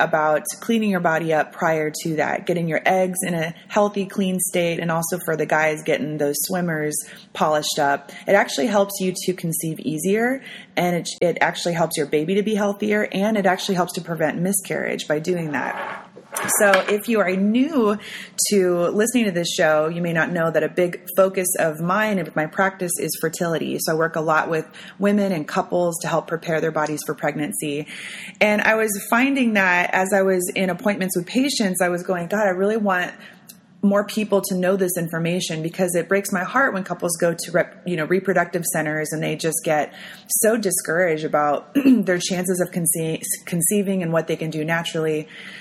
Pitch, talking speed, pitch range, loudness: 180 Hz, 200 wpm, 160-200 Hz, -21 LUFS